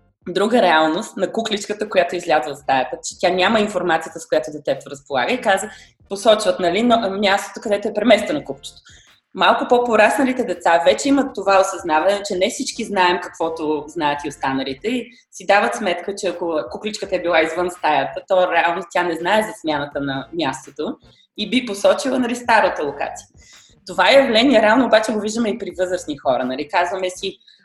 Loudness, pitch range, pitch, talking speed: -18 LUFS, 170-220 Hz, 190 Hz, 175 wpm